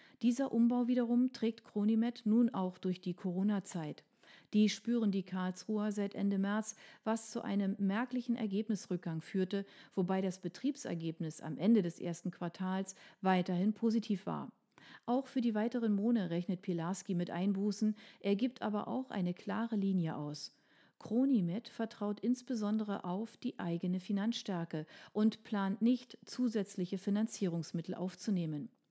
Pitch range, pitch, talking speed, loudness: 185-230 Hz, 205 Hz, 135 wpm, -36 LUFS